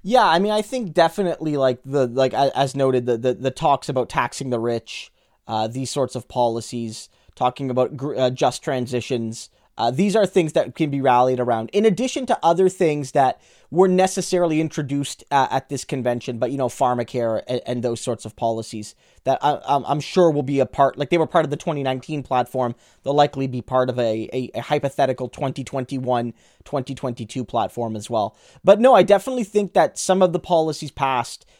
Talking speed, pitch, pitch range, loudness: 195 wpm, 135 Hz, 125-160 Hz, -21 LUFS